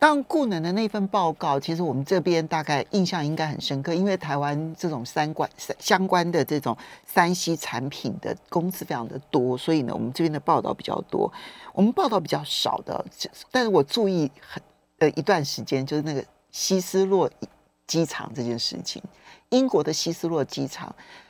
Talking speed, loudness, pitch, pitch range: 280 characters per minute, -25 LUFS, 160 Hz, 145-180 Hz